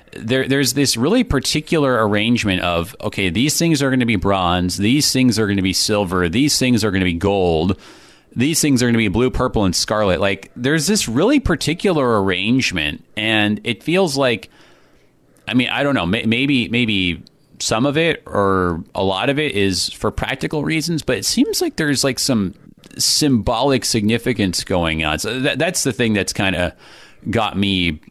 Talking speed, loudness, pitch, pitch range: 190 wpm, -17 LUFS, 115 Hz, 95-140 Hz